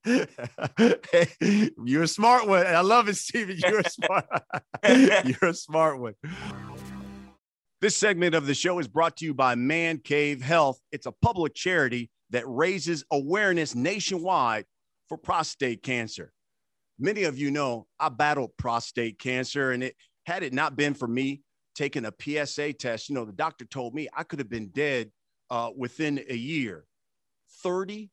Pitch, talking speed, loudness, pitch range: 145 Hz, 160 wpm, -26 LUFS, 125-170 Hz